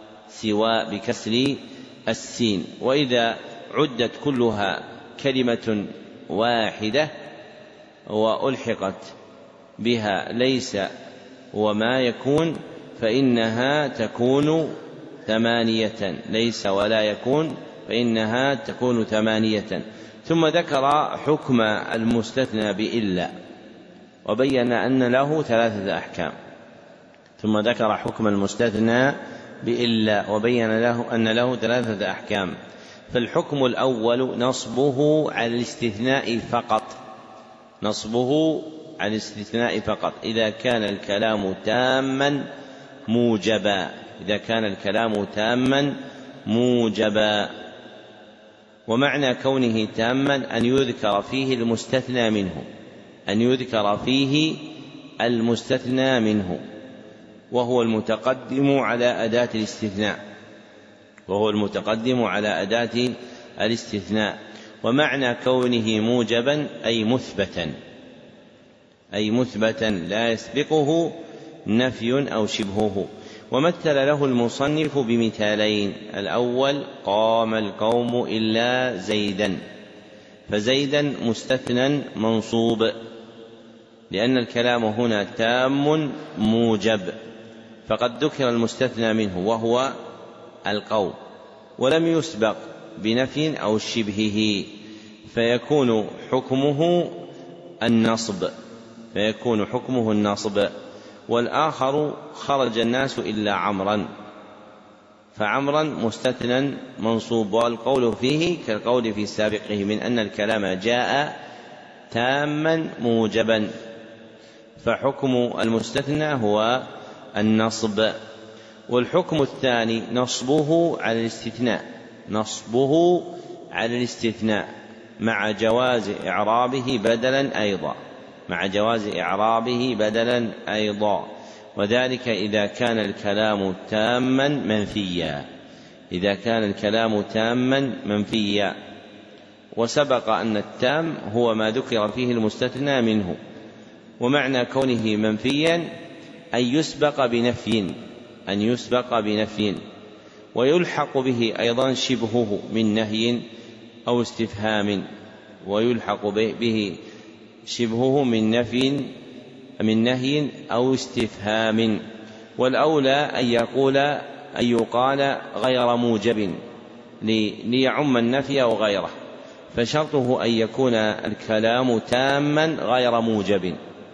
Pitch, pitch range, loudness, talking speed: 115 Hz, 110-130 Hz, -22 LUFS, 80 wpm